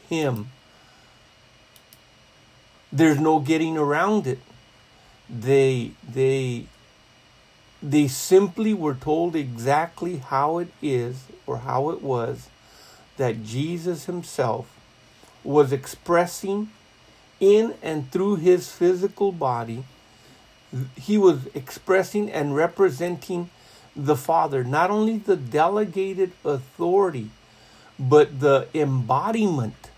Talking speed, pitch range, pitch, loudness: 90 wpm, 125-175 Hz, 145 Hz, -23 LUFS